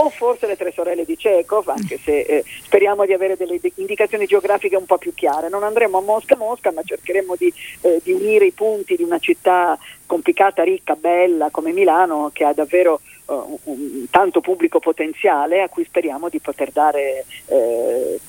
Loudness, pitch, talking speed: -18 LUFS, 190 Hz, 185 wpm